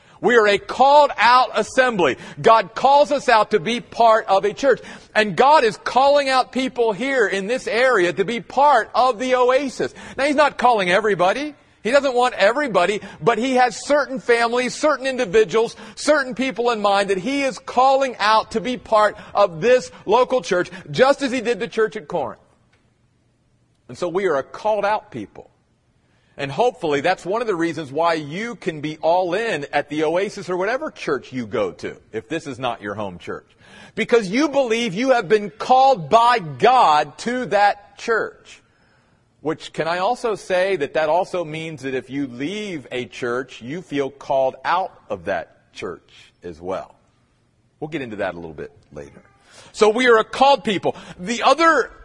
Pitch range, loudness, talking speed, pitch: 180-255 Hz, -19 LUFS, 185 wpm, 220 Hz